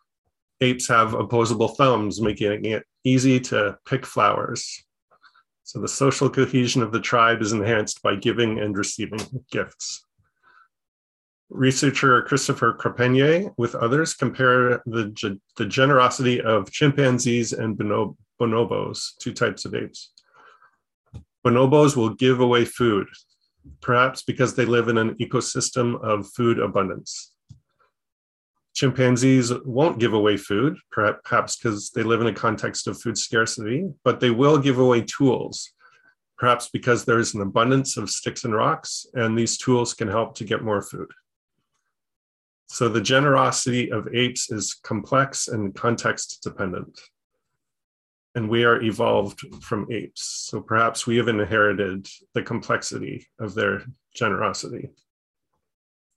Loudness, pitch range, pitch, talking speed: -22 LUFS, 110-130 Hz, 120 Hz, 130 wpm